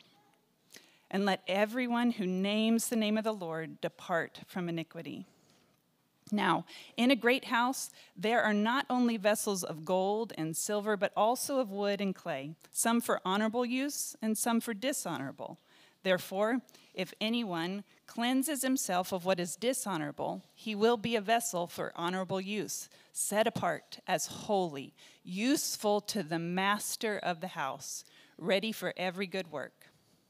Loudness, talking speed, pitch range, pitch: -33 LUFS, 145 wpm, 185-230 Hz, 210 Hz